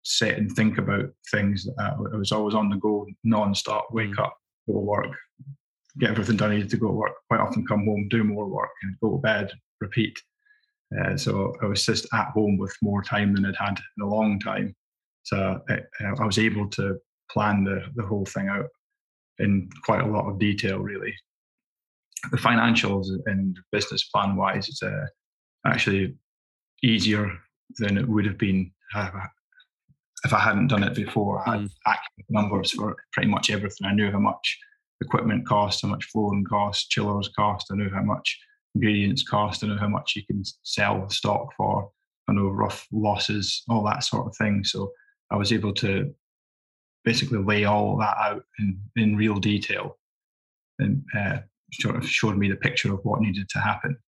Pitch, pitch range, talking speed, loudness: 105 Hz, 100-115 Hz, 185 wpm, -25 LUFS